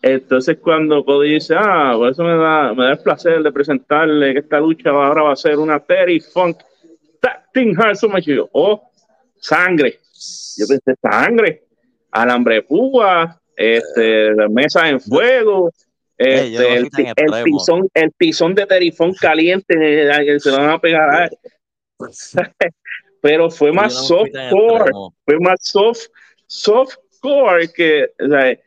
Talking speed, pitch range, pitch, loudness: 140 wpm, 145-190 Hz, 160 Hz, -14 LUFS